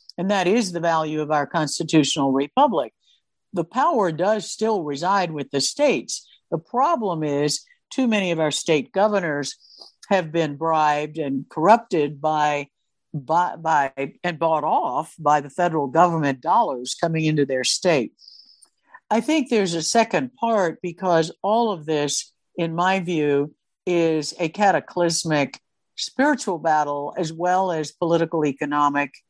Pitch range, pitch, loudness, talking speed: 150-190 Hz, 165 Hz, -22 LUFS, 140 wpm